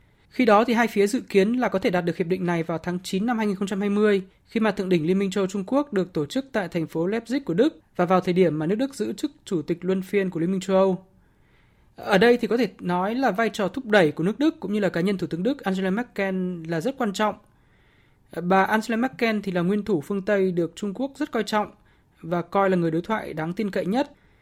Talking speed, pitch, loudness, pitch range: 270 wpm, 195 Hz, -24 LUFS, 180-220 Hz